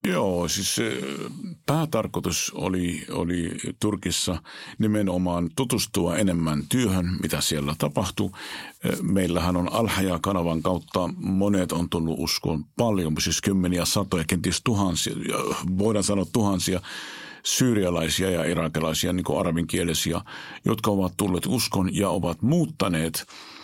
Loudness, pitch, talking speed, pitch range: -25 LUFS, 90 Hz, 110 wpm, 85-100 Hz